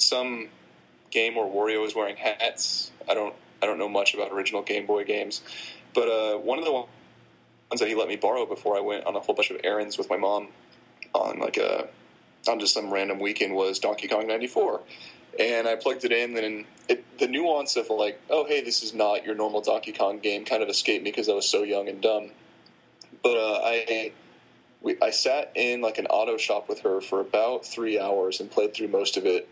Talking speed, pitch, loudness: 220 wpm, 115 Hz, -26 LUFS